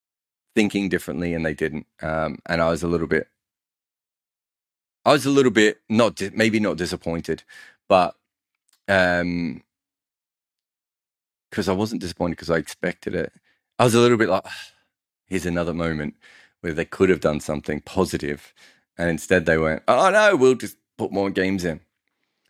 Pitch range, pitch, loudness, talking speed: 80-100 Hz, 90 Hz, -22 LUFS, 165 wpm